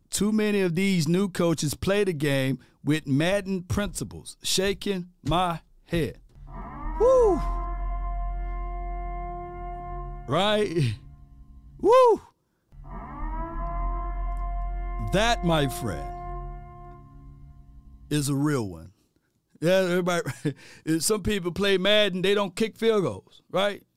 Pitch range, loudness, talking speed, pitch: 130-205 Hz, -26 LUFS, 95 wpm, 175 Hz